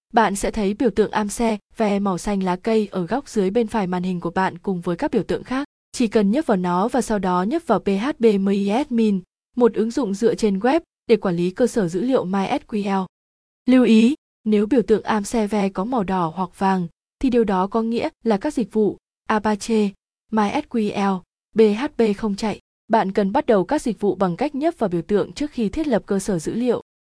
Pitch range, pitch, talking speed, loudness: 195-235 Hz, 215 Hz, 220 wpm, -21 LUFS